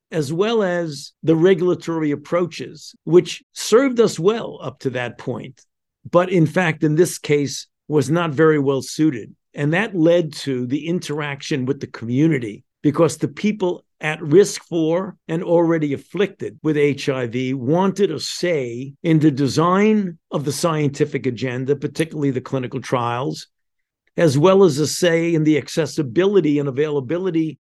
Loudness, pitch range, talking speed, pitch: -19 LUFS, 140-175 Hz, 150 wpm, 155 Hz